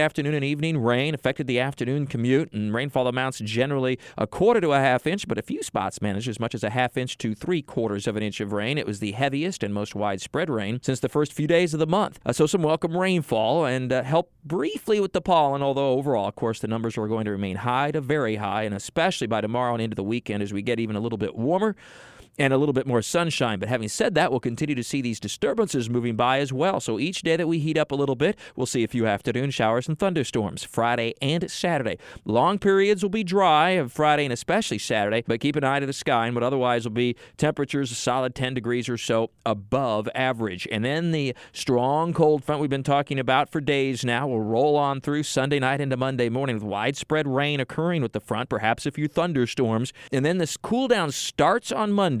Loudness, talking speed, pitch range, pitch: -24 LUFS, 240 wpm, 115-150 Hz, 130 Hz